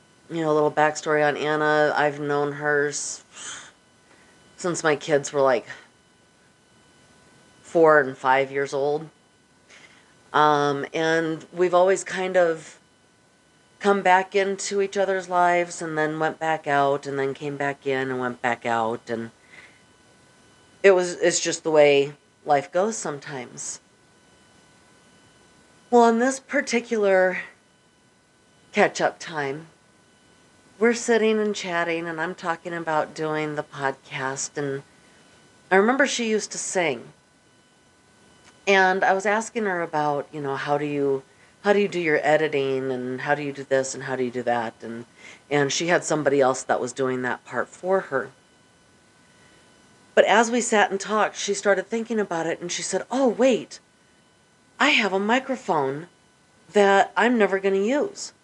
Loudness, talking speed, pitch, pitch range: -23 LUFS, 150 wpm, 160 Hz, 140-190 Hz